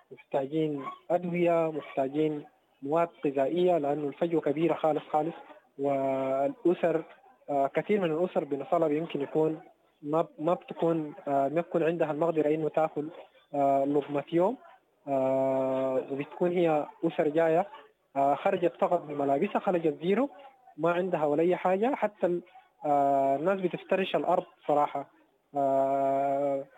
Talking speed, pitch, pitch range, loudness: 105 wpm, 160 Hz, 140-175 Hz, -29 LUFS